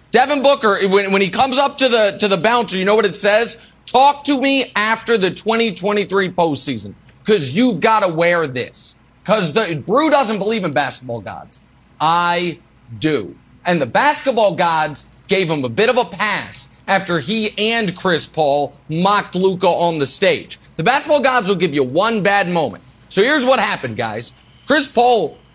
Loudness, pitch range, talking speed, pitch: -16 LUFS, 170-230 Hz, 180 wpm, 200 Hz